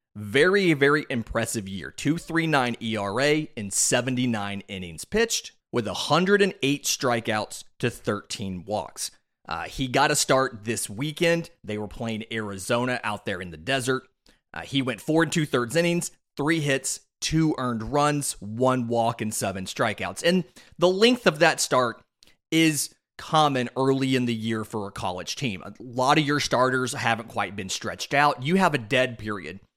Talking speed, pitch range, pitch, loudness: 165 wpm, 110-150 Hz, 130 Hz, -25 LUFS